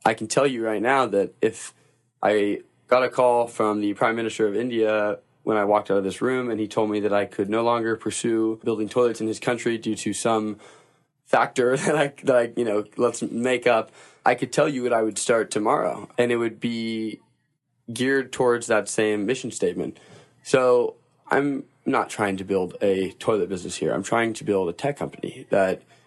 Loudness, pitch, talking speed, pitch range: -23 LUFS, 115 Hz, 205 wpm, 105-120 Hz